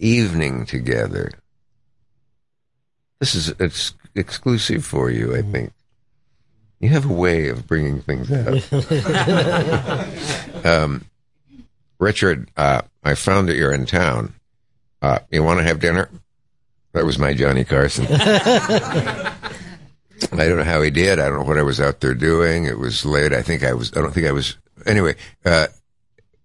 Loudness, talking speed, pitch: -19 LUFS, 150 wpm, 100 Hz